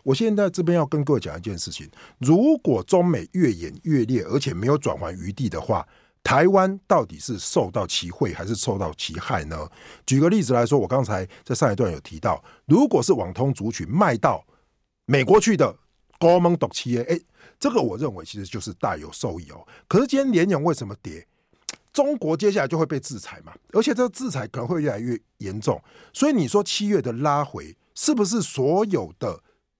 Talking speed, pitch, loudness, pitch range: 290 characters per minute, 145 Hz, -22 LUFS, 110-185 Hz